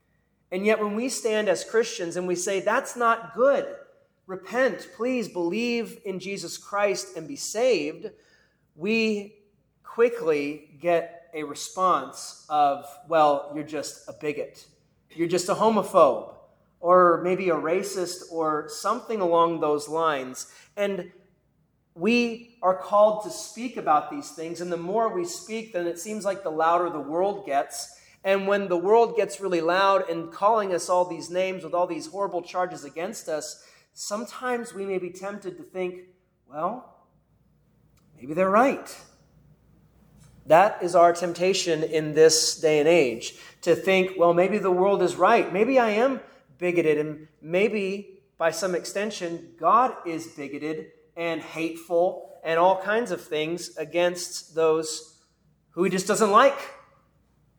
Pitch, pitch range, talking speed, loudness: 180 Hz, 165-205 Hz, 150 wpm, -24 LUFS